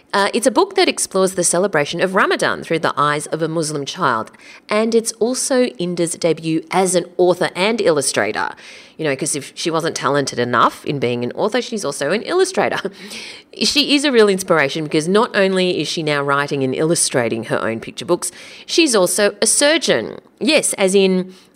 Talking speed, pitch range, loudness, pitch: 190 wpm, 150-210 Hz, -17 LUFS, 175 Hz